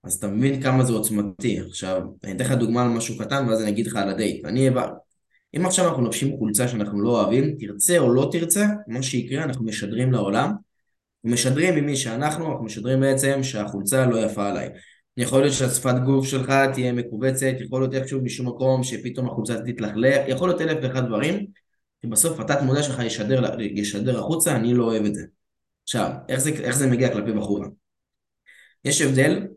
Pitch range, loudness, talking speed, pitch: 110-135 Hz, -22 LUFS, 180 wpm, 125 Hz